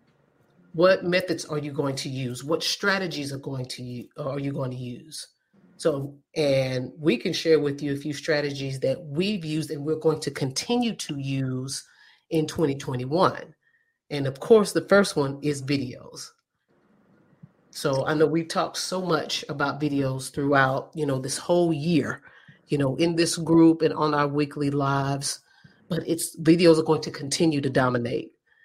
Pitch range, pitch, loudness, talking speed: 140-165 Hz, 150 Hz, -25 LUFS, 170 wpm